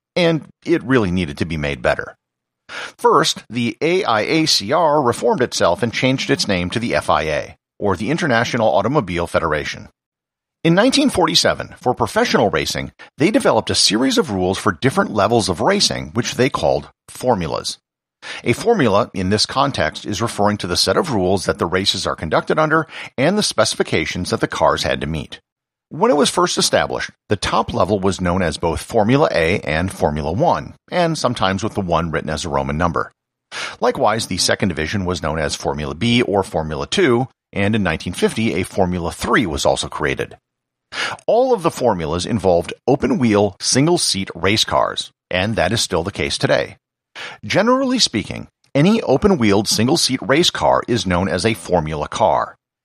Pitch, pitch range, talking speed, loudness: 100 Hz, 90-125 Hz, 175 wpm, -17 LUFS